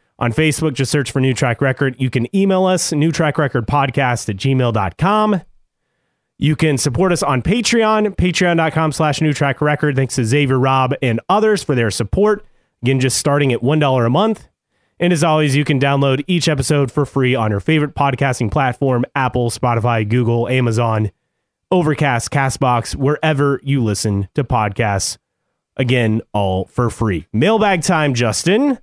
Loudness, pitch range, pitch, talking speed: -16 LUFS, 120-155 Hz, 140 Hz, 150 wpm